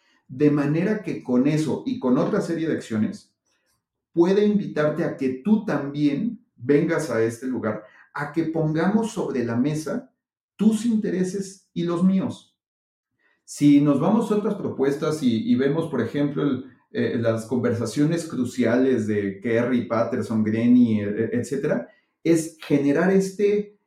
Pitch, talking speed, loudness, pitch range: 150 Hz, 140 wpm, -23 LUFS, 125-190 Hz